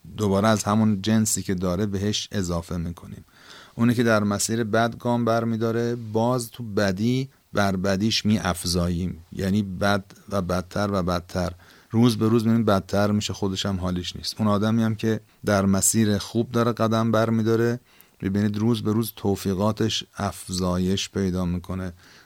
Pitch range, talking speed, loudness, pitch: 95-115 Hz, 155 wpm, -24 LUFS, 105 Hz